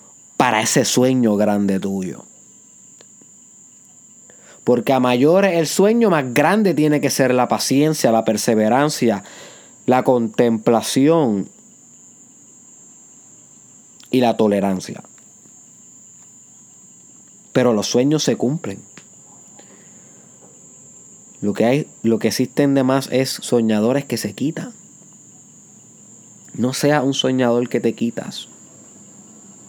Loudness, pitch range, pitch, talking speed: -17 LUFS, 115-145 Hz, 125 Hz, 100 wpm